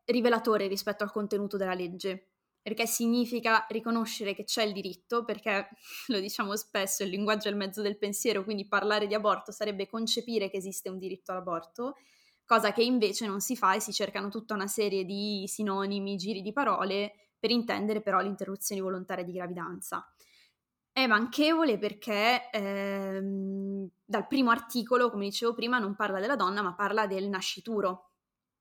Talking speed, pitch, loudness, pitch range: 165 wpm, 205 Hz, -30 LUFS, 195-225 Hz